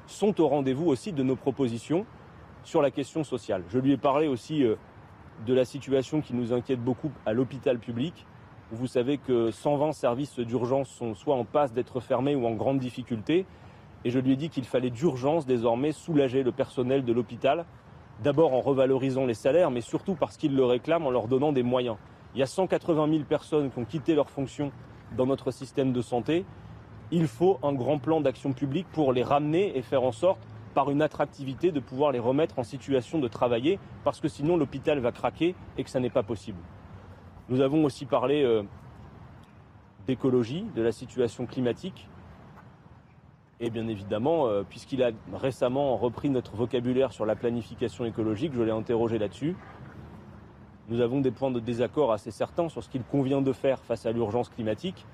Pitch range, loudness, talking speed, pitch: 120-145 Hz, -28 LUFS, 185 wpm, 130 Hz